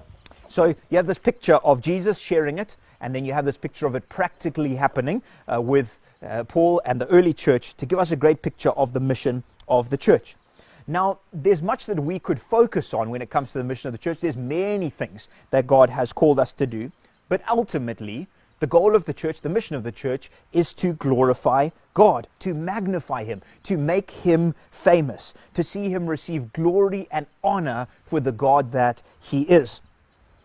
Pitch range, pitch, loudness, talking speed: 130-180 Hz, 150 Hz, -22 LUFS, 200 wpm